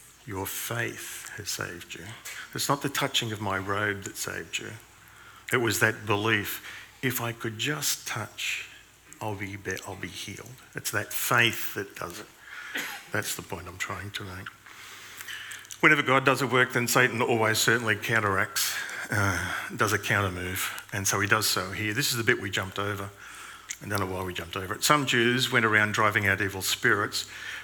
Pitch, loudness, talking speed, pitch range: 105 Hz, -27 LUFS, 185 wpm, 100-120 Hz